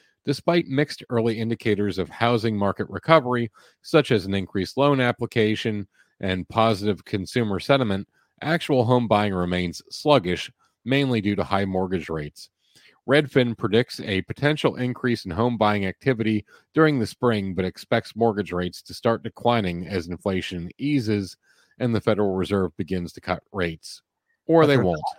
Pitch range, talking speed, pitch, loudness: 95-125 Hz, 150 wpm, 110 Hz, -23 LUFS